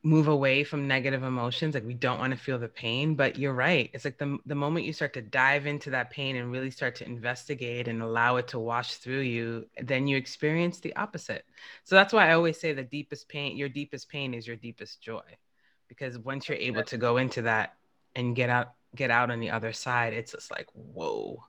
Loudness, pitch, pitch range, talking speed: -28 LUFS, 130 Hz, 120-145 Hz, 230 wpm